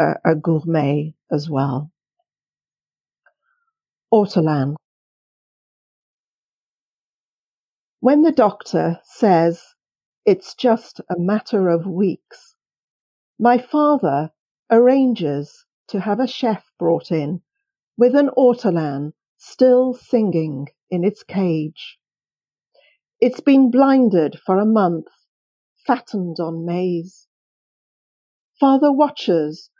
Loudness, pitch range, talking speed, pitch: -18 LUFS, 165-260 Hz, 85 wpm, 200 Hz